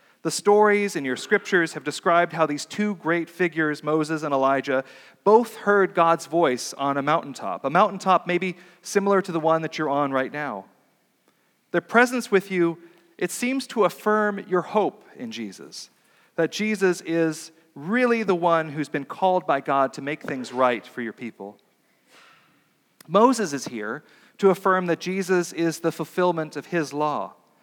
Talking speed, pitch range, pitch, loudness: 165 wpm, 150-195 Hz, 170 Hz, -23 LUFS